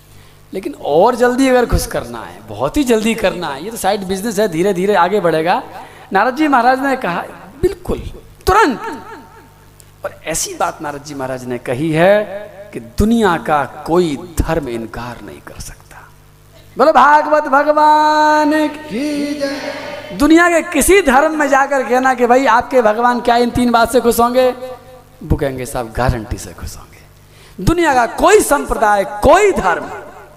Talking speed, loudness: 155 wpm, -14 LUFS